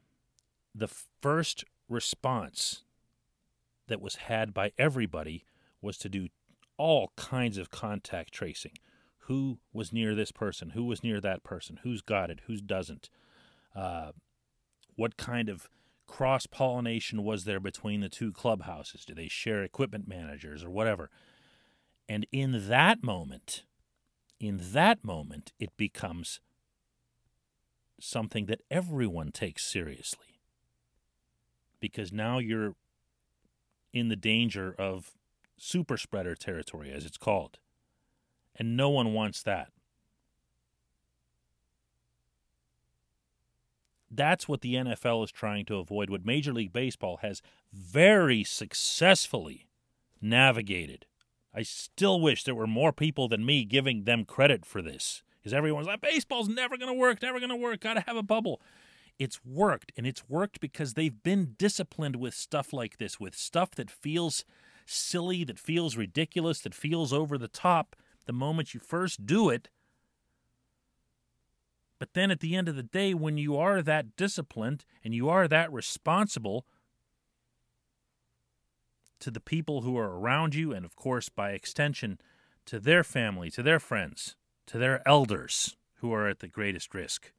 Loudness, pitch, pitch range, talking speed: -30 LUFS, 115 Hz, 100-150 Hz, 140 wpm